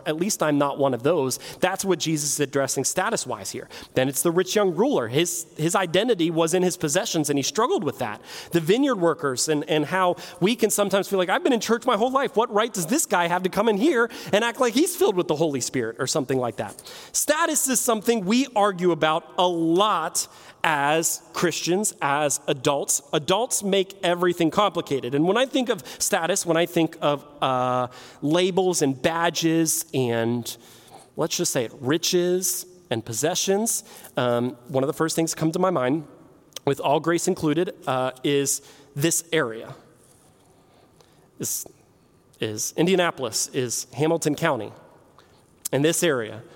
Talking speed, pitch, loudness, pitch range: 180 wpm, 165 Hz, -23 LUFS, 145-190 Hz